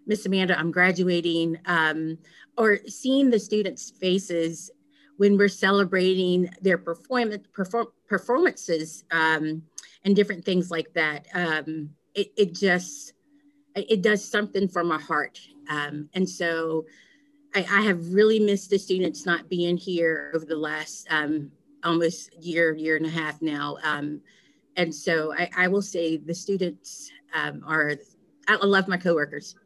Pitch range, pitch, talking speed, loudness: 160-200 Hz, 180 Hz, 145 wpm, -25 LUFS